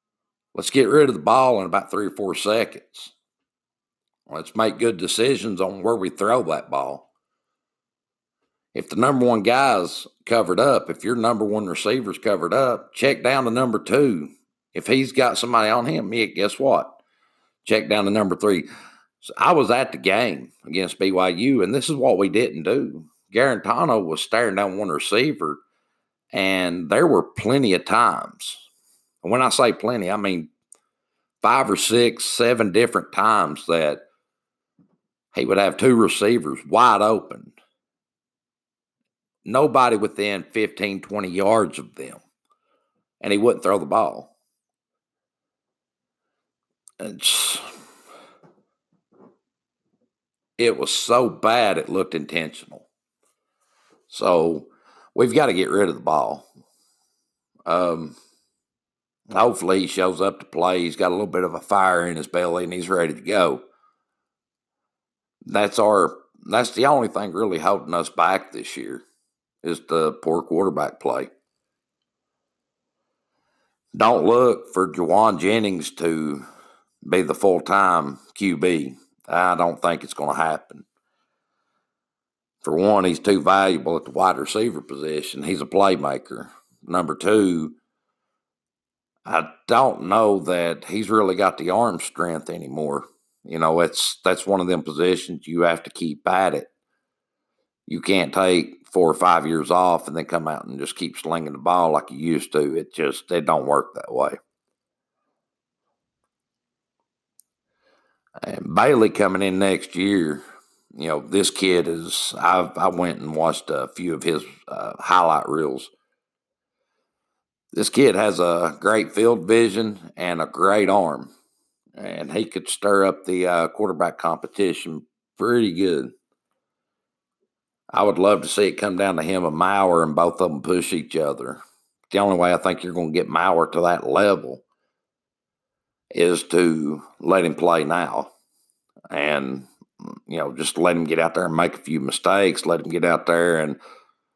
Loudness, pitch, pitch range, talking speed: -20 LUFS, 90 Hz, 85-105 Hz, 150 wpm